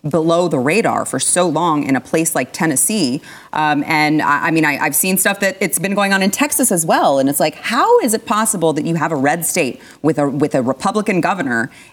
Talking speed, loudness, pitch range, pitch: 240 wpm, -15 LUFS, 150-195 Hz, 165 Hz